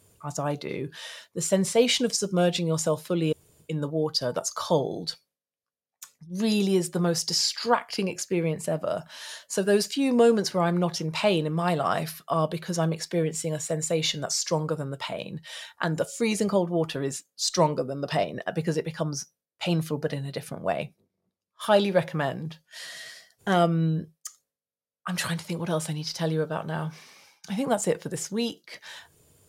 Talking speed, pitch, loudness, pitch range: 175 wpm, 165 Hz, -27 LUFS, 155-190 Hz